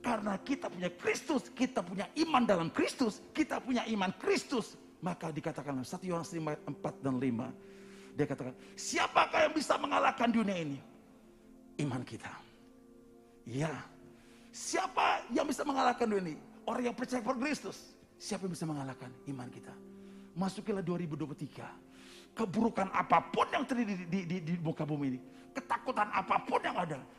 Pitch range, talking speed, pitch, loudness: 150-240 Hz, 150 wpm, 195 Hz, -35 LUFS